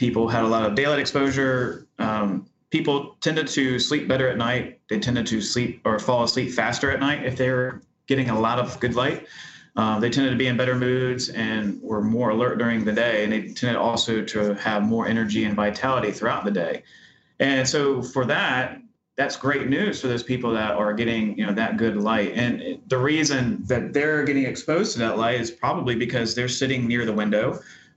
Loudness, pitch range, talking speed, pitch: -23 LUFS, 110-130 Hz, 210 wpm, 120 Hz